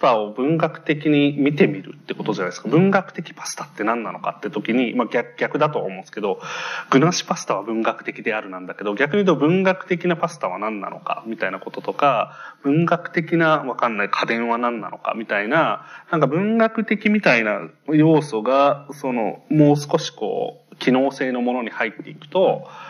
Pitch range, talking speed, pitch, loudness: 125-175 Hz, 390 characters per minute, 150 Hz, -21 LUFS